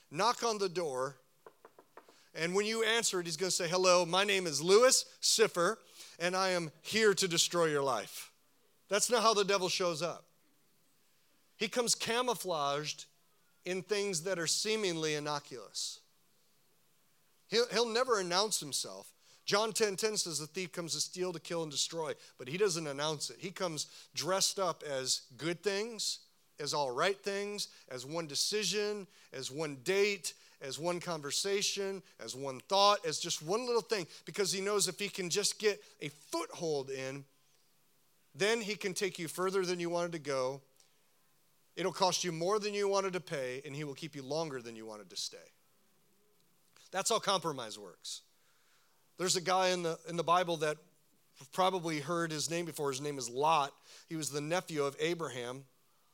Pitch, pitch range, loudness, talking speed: 180 Hz, 155-200 Hz, -33 LUFS, 175 wpm